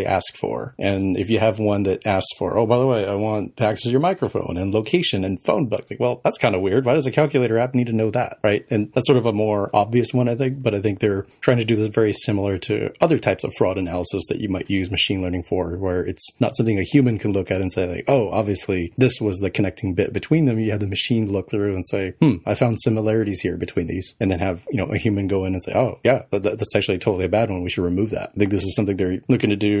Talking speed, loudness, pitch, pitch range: 285 wpm, -21 LUFS, 105 Hz, 95-115 Hz